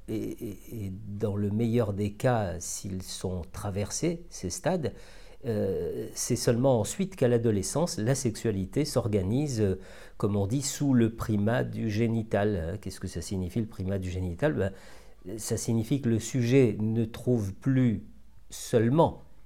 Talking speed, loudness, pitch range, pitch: 150 wpm, -29 LUFS, 100-125 Hz, 110 Hz